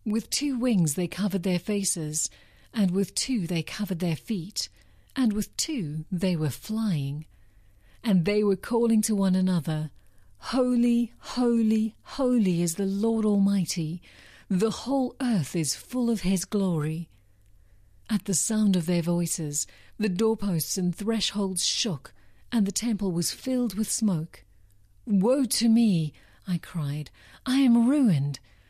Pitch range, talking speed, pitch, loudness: 155-220 Hz, 140 wpm, 190 Hz, -26 LUFS